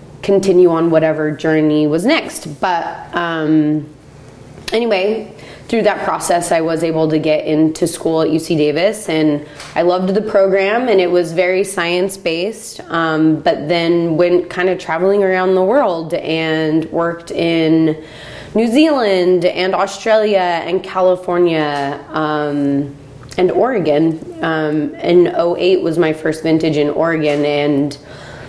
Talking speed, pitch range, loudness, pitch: 135 wpm, 155-185 Hz, -15 LUFS, 165 Hz